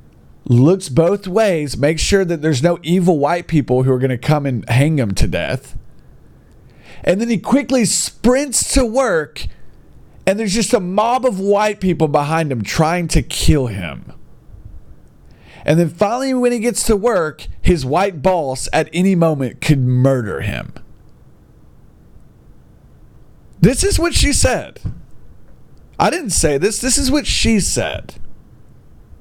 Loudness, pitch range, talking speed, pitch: -16 LUFS, 150-225 Hz, 150 wpm, 180 Hz